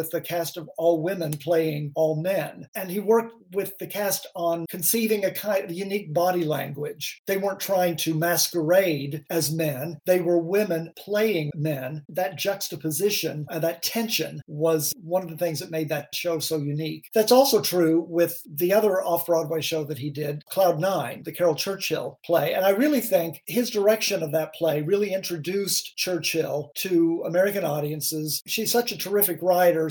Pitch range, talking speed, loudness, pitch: 160-195 Hz, 175 wpm, -24 LUFS, 170 Hz